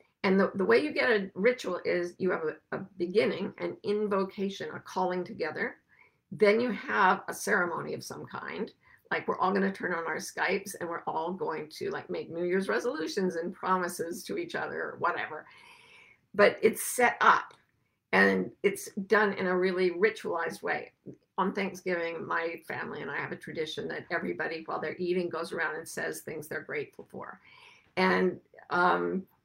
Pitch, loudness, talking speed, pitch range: 190 Hz, -30 LUFS, 180 wpm, 175-215 Hz